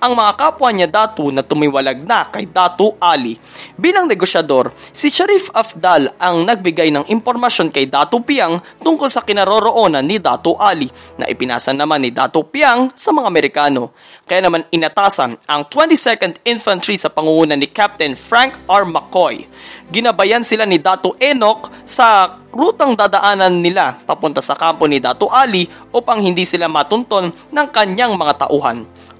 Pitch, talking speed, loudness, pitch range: 190 Hz, 150 wpm, -13 LUFS, 155-235 Hz